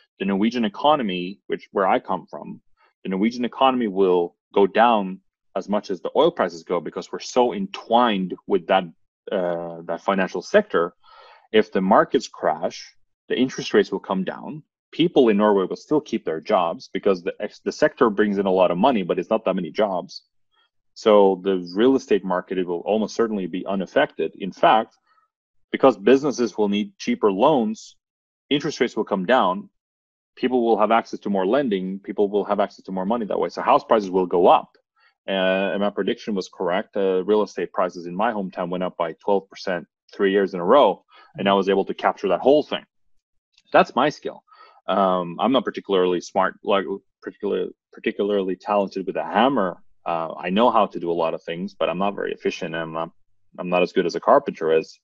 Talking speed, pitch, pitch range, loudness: 200 wpm, 100 Hz, 90-110 Hz, -22 LUFS